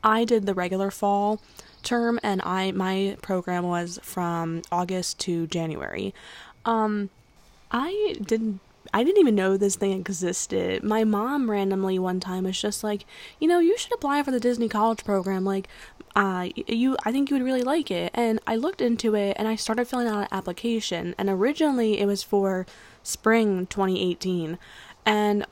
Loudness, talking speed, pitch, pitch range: -25 LUFS, 175 wpm, 200 Hz, 185-230 Hz